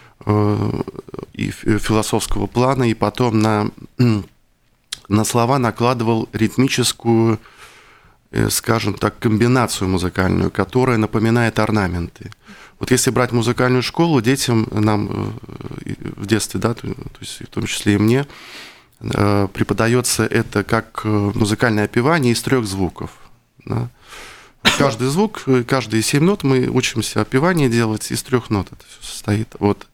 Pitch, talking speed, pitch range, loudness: 115 Hz, 120 wpm, 105-125 Hz, -18 LUFS